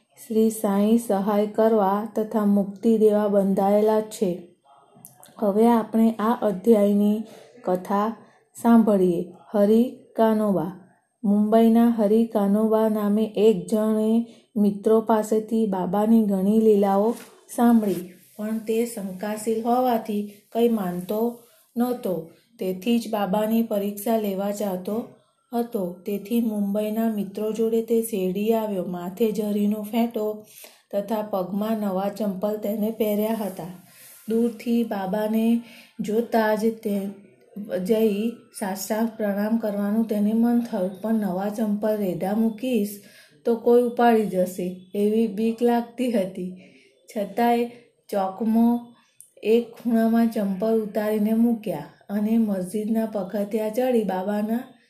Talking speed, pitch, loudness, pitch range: 105 wpm, 215 Hz, -23 LUFS, 205-230 Hz